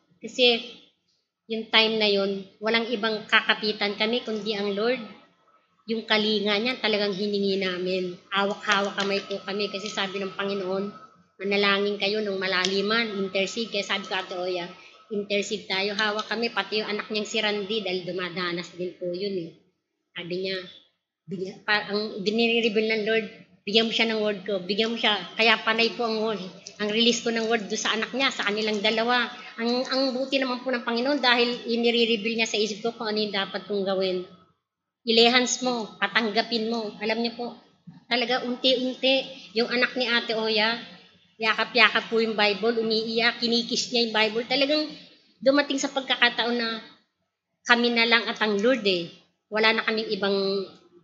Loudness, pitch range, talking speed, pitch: -24 LUFS, 200-230 Hz, 165 wpm, 215 Hz